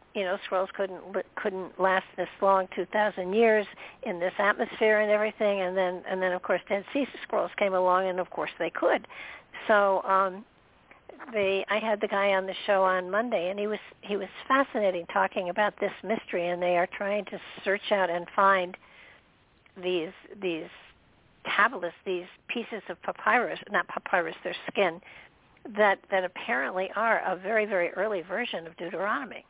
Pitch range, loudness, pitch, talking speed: 185-210 Hz, -28 LUFS, 195 Hz, 175 wpm